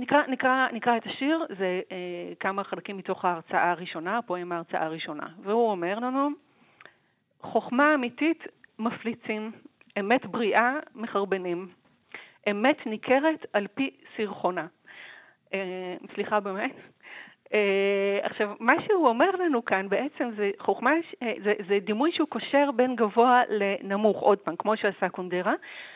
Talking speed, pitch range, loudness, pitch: 130 wpm, 195-260 Hz, -27 LUFS, 220 Hz